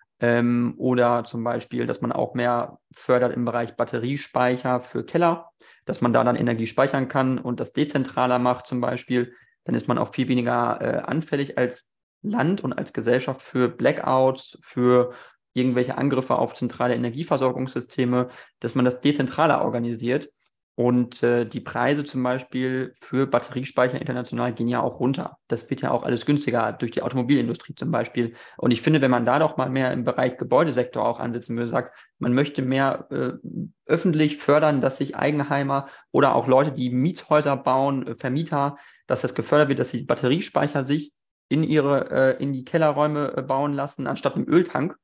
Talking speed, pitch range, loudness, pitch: 170 wpm, 125-140 Hz, -23 LUFS, 130 Hz